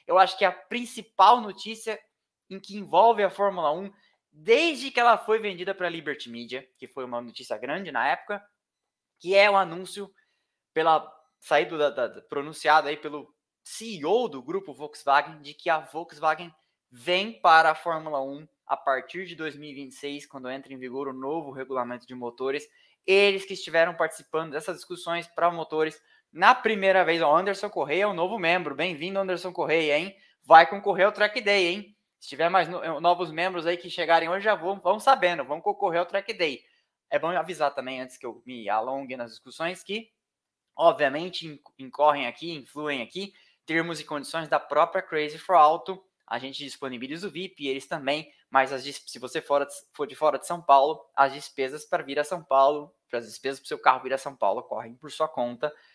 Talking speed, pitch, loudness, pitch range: 190 wpm, 160 Hz, -25 LUFS, 140-190 Hz